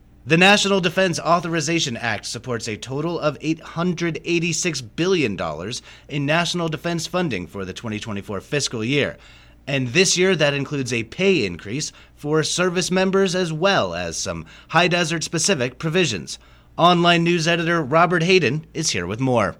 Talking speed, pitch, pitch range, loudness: 145 wpm, 160 Hz, 120-175 Hz, -20 LUFS